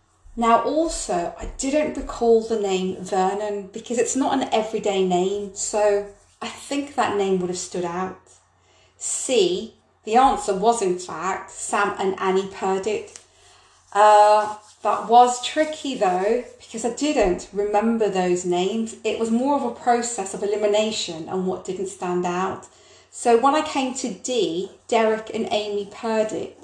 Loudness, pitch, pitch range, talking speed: -22 LUFS, 215 Hz, 190-250 Hz, 150 wpm